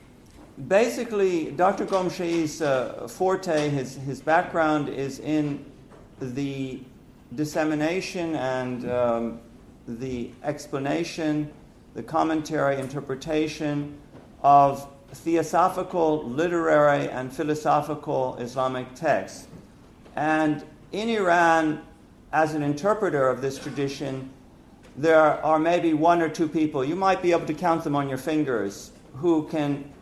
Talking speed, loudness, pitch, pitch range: 110 wpm, -25 LUFS, 150 Hz, 135-165 Hz